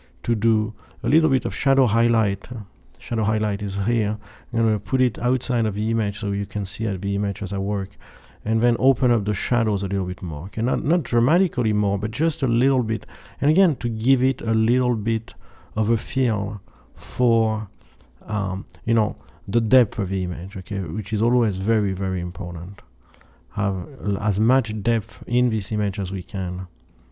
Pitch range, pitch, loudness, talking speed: 100-120 Hz, 110 Hz, -22 LUFS, 195 wpm